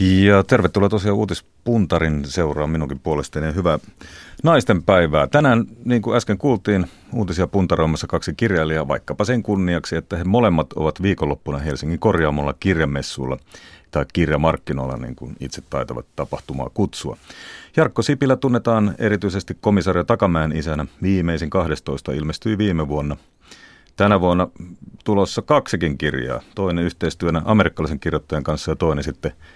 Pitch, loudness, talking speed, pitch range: 85 Hz, -20 LUFS, 130 wpm, 75-105 Hz